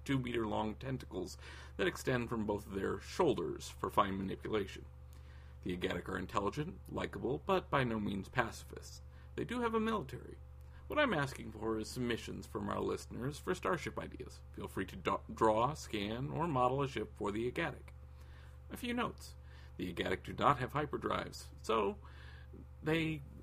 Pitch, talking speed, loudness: 95 Hz, 165 wpm, -38 LUFS